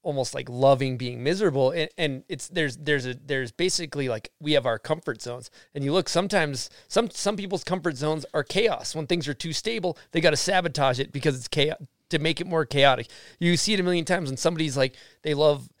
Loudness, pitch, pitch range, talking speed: -25 LUFS, 155 Hz, 140-175 Hz, 225 wpm